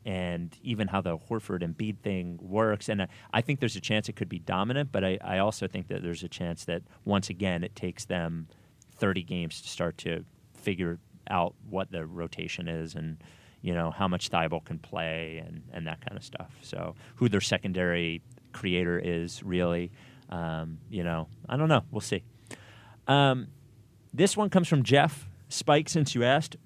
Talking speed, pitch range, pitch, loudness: 190 wpm, 85-120 Hz, 100 Hz, -30 LUFS